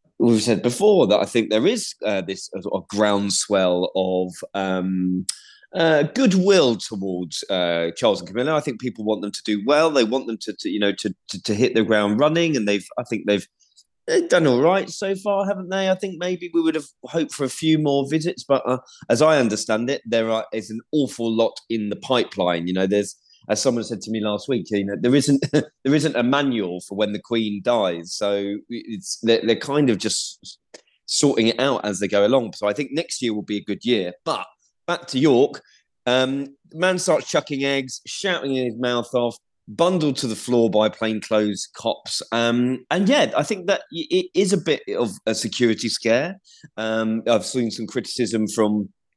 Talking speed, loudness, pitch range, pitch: 210 wpm, -21 LUFS, 105-150 Hz, 115 Hz